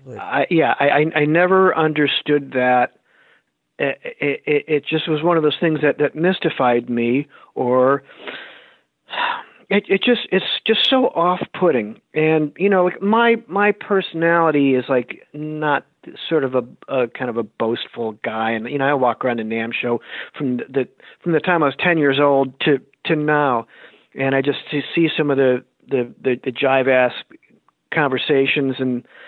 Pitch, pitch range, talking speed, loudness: 145 Hz, 125-165 Hz, 180 wpm, -18 LUFS